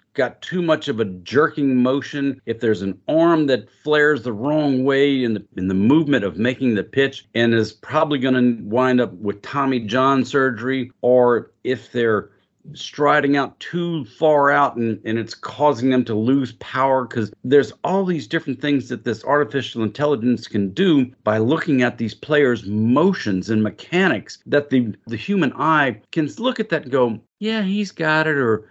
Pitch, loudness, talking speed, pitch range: 130 Hz, -19 LUFS, 180 wpm, 115-150 Hz